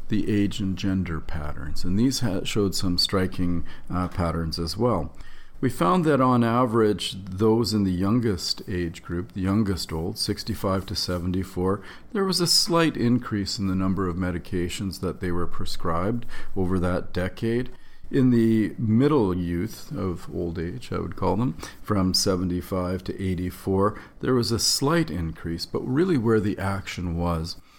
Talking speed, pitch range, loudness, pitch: 160 wpm, 90-110 Hz, -25 LUFS, 95 Hz